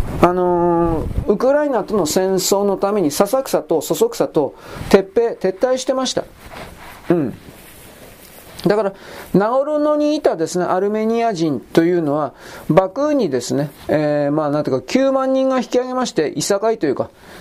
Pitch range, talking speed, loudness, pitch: 170-260 Hz, 290 characters per minute, -18 LUFS, 200 Hz